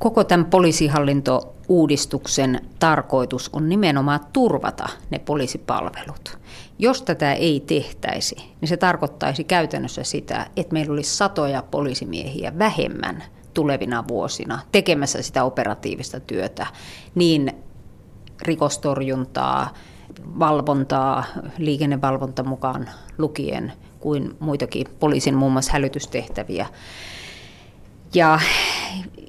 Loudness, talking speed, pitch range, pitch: -21 LUFS, 90 wpm, 135-165 Hz, 145 Hz